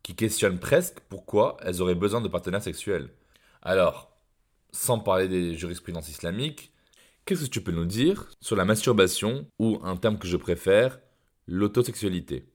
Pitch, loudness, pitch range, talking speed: 95 Hz, -26 LUFS, 90-110 Hz, 155 wpm